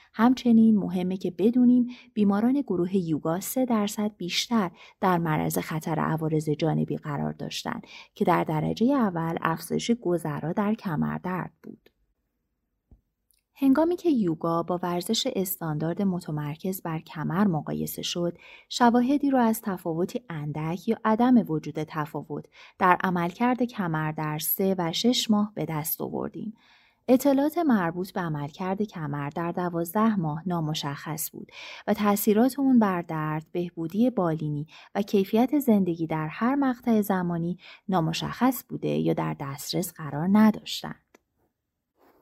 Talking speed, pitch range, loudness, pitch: 125 wpm, 155-225 Hz, -26 LUFS, 180 Hz